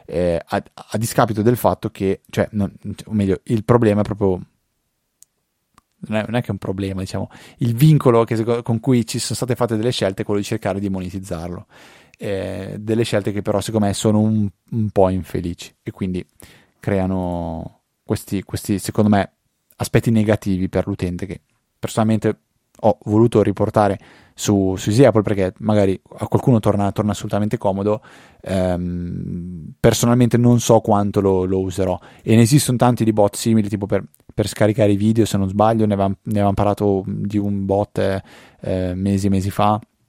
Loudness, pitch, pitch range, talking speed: -19 LUFS, 105 Hz, 95-115 Hz, 170 wpm